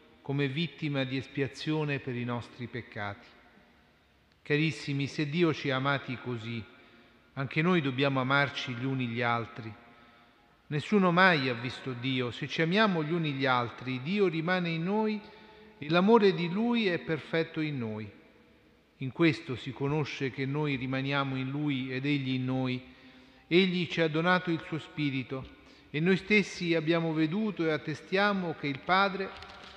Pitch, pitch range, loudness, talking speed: 140 Hz, 130-170 Hz, -30 LUFS, 155 wpm